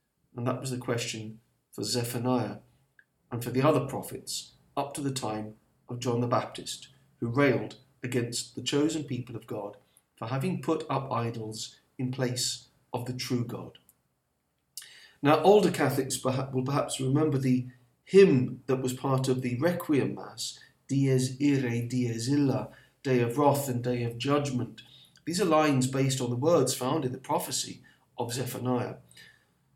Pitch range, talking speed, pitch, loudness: 125-140 Hz, 160 wpm, 130 Hz, -29 LUFS